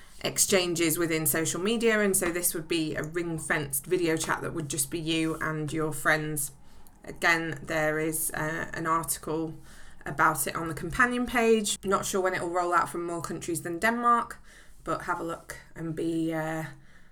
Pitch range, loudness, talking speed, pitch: 160-180 Hz, -28 LUFS, 185 wpm, 165 Hz